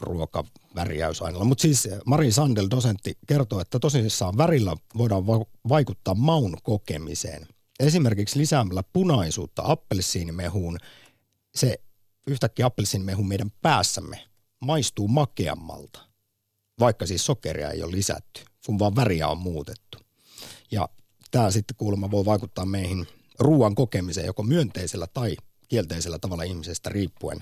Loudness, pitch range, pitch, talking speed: -25 LUFS, 95-125 Hz, 105 Hz, 115 wpm